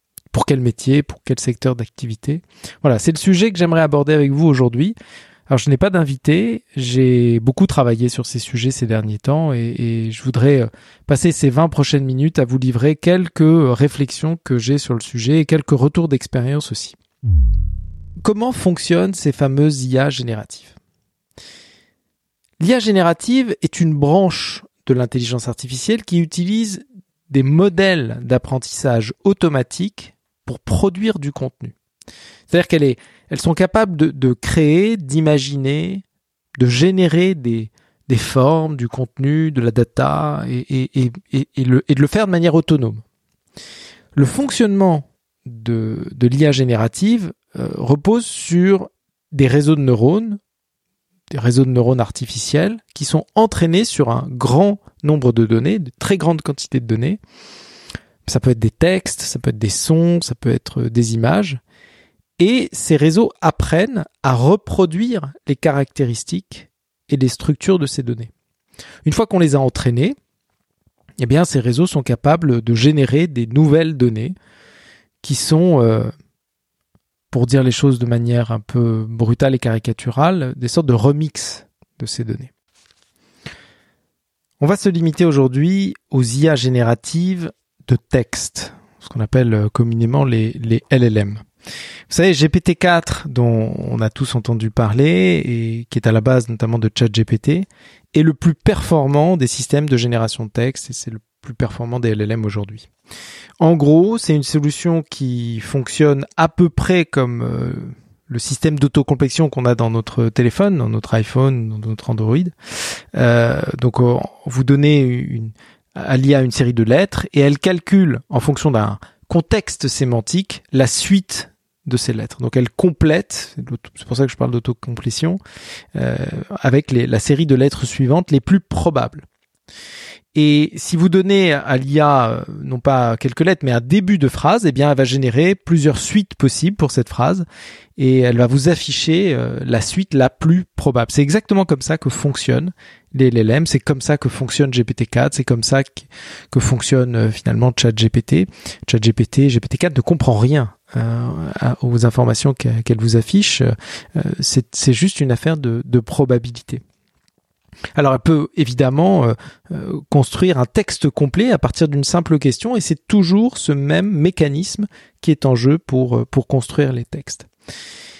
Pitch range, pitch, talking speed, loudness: 120-165 Hz, 140 Hz, 155 wpm, -16 LUFS